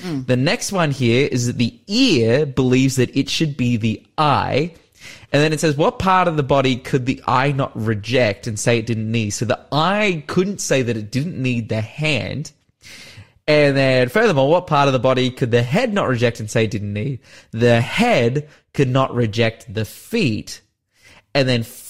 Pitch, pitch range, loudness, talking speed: 130 Hz, 115-145 Hz, -18 LUFS, 195 wpm